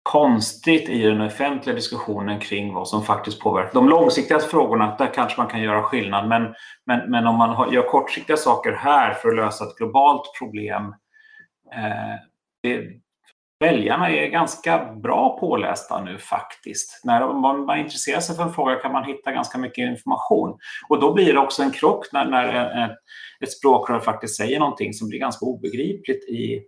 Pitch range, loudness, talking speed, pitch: 110-135 Hz, -21 LUFS, 175 wpm, 120 Hz